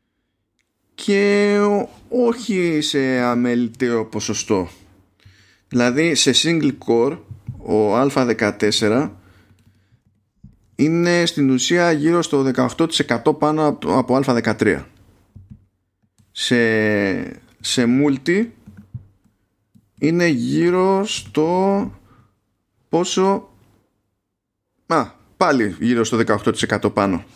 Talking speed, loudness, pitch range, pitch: 70 wpm, -18 LUFS, 105-150 Hz, 120 Hz